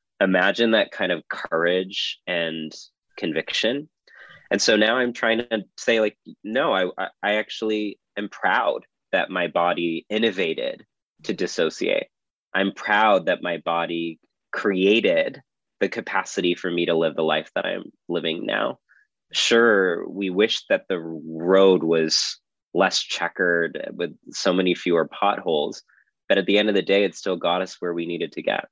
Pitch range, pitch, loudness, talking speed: 85-105 Hz, 90 Hz, -22 LUFS, 155 wpm